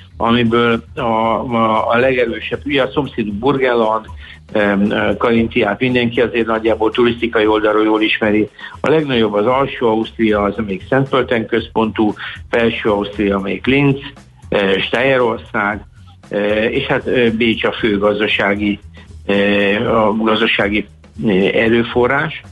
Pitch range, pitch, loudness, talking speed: 100-115 Hz, 110 Hz, -15 LUFS, 125 wpm